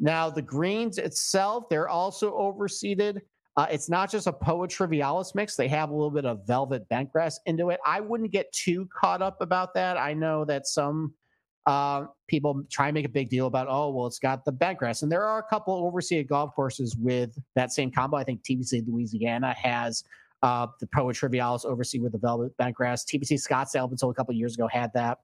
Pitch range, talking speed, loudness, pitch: 125-175 Hz, 210 wpm, -28 LUFS, 145 Hz